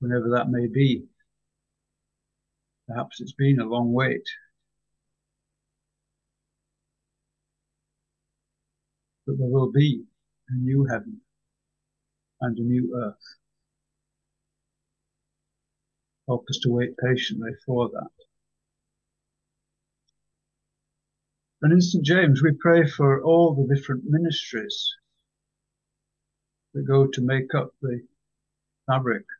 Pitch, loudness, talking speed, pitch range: 135 Hz, -23 LUFS, 95 wpm, 125-160 Hz